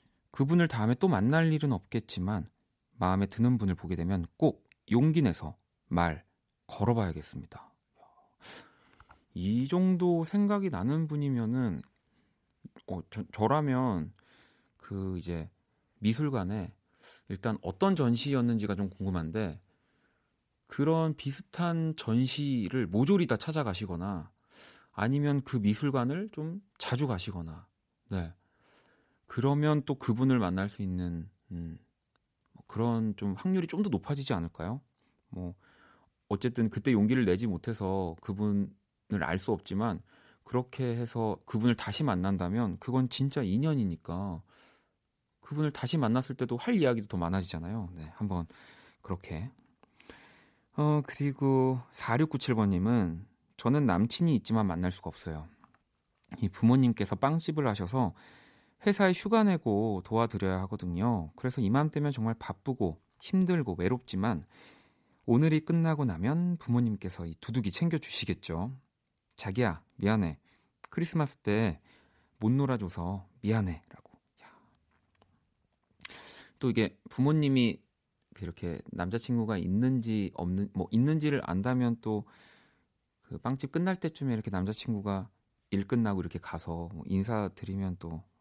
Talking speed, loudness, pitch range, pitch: 265 characters per minute, -31 LUFS, 95-135 Hz, 115 Hz